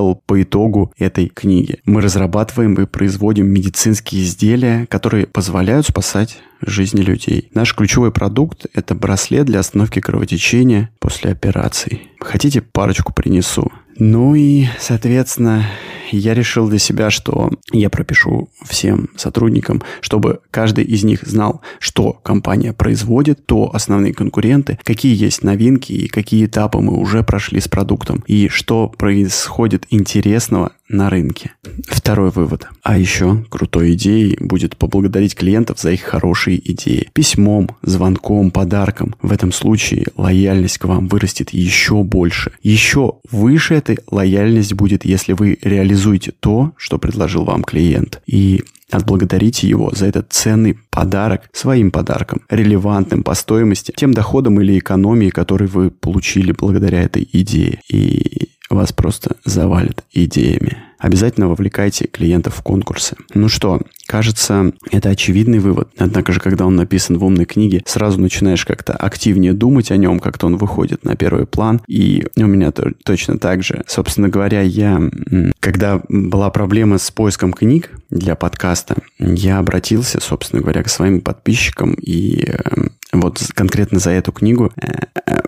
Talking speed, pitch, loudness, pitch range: 140 wpm, 100 Hz, -14 LUFS, 95-110 Hz